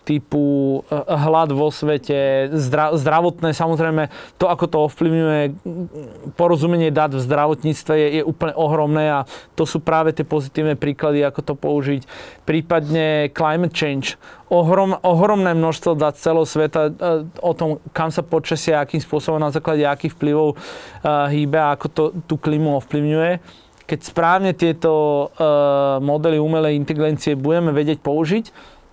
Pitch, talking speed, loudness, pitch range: 155 Hz, 135 wpm, -18 LUFS, 150-165 Hz